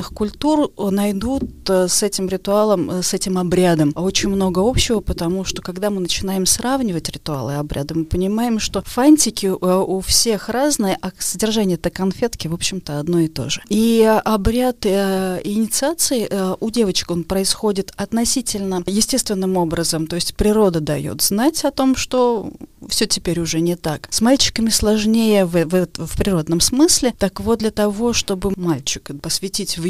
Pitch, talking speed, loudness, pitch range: 195 Hz, 155 wpm, -18 LUFS, 180-220 Hz